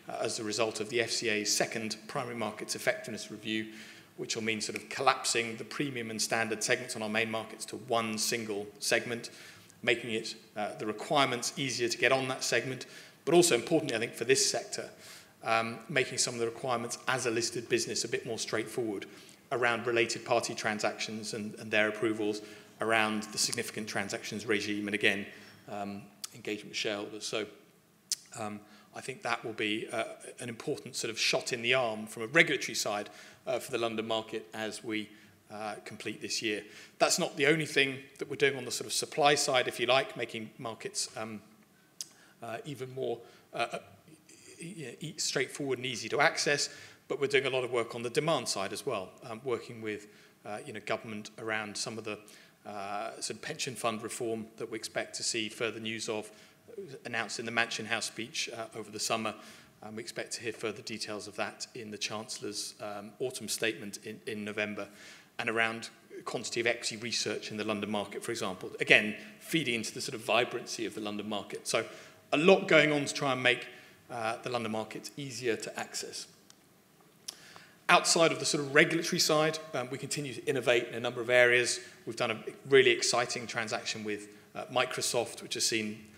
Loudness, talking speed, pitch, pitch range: -32 LUFS, 195 wpm, 115 Hz, 110-125 Hz